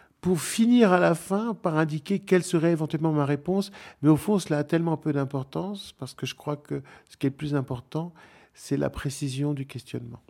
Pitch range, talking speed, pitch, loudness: 145-185 Hz, 210 wpm, 155 Hz, -26 LUFS